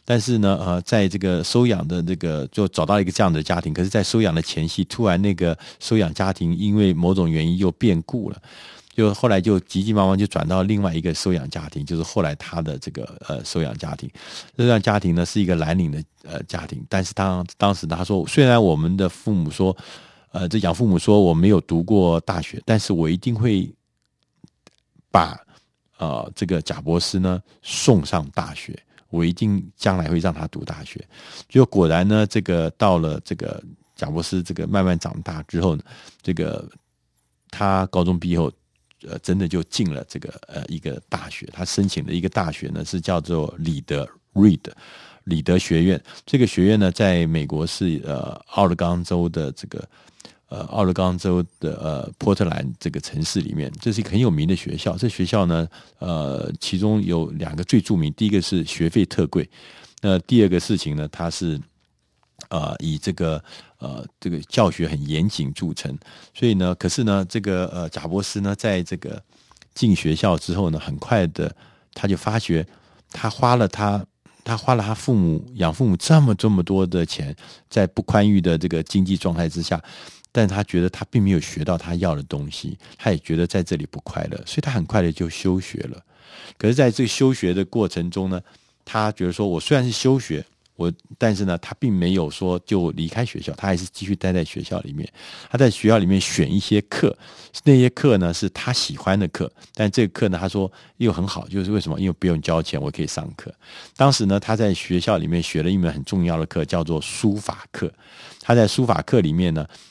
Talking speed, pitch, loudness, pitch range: 285 characters per minute, 95 Hz, -21 LUFS, 85-105 Hz